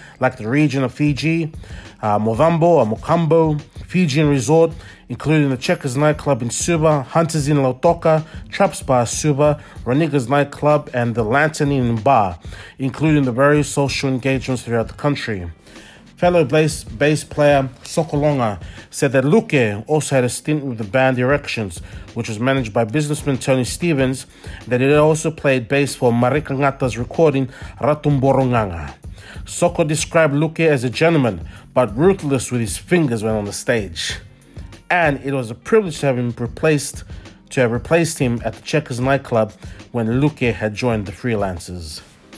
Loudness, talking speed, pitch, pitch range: -18 LUFS, 155 wpm, 135 Hz, 115-150 Hz